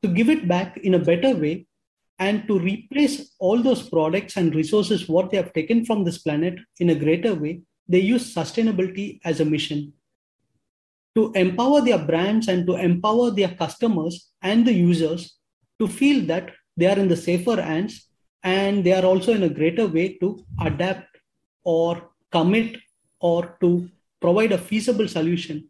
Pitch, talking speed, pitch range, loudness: 185 Hz, 170 wpm, 170-215 Hz, -21 LUFS